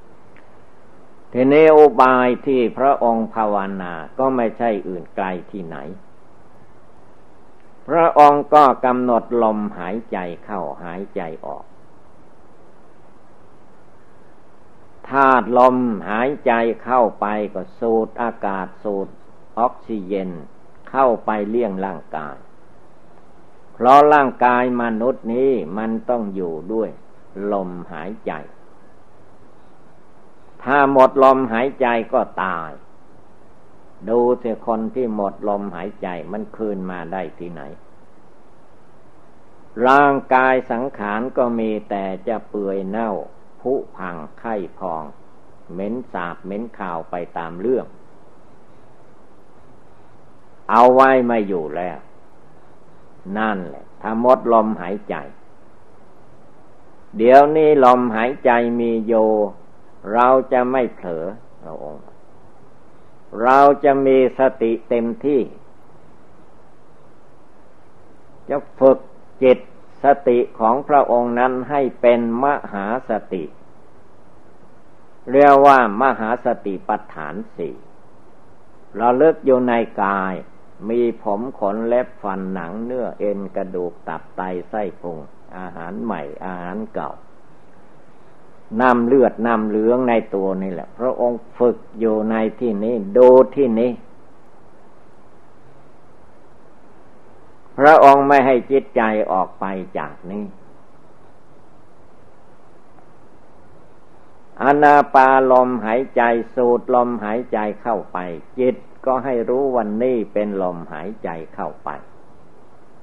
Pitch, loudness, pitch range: 120 Hz, -17 LUFS, 105-130 Hz